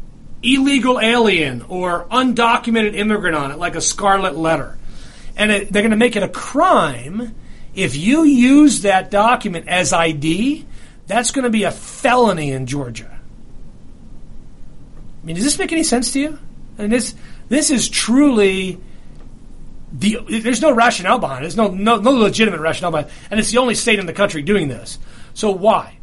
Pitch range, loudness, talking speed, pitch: 165-245 Hz, -16 LUFS, 180 wpm, 210 Hz